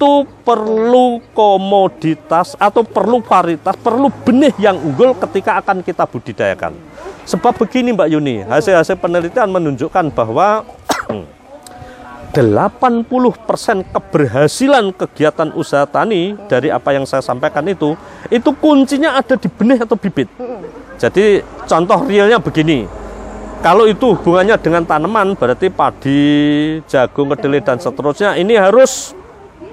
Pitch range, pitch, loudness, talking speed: 155-235 Hz, 195 Hz, -13 LUFS, 115 wpm